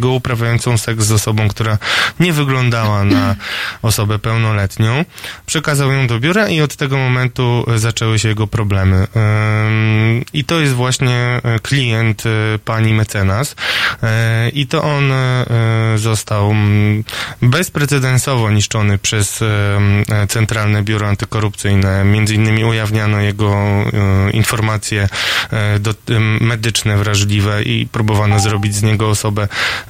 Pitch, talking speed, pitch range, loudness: 110 Hz, 105 wpm, 105-120 Hz, -14 LUFS